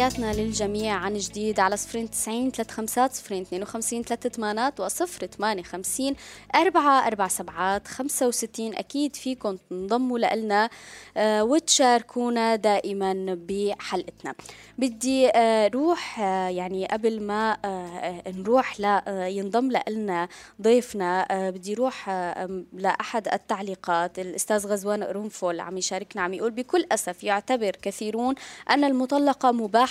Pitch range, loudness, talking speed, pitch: 190-245 Hz, -25 LUFS, 130 wpm, 215 Hz